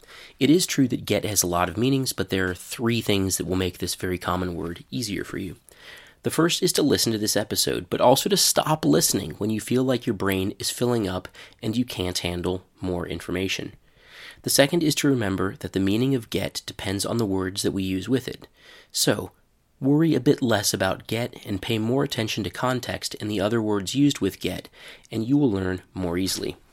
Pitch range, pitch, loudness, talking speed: 95-125 Hz, 105 Hz, -24 LUFS, 220 wpm